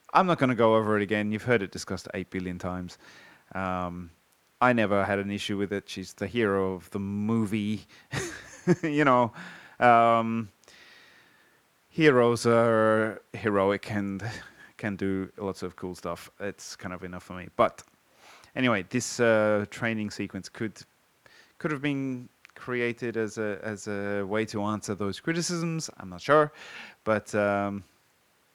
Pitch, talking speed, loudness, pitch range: 105 Hz, 155 wpm, -27 LUFS, 95-120 Hz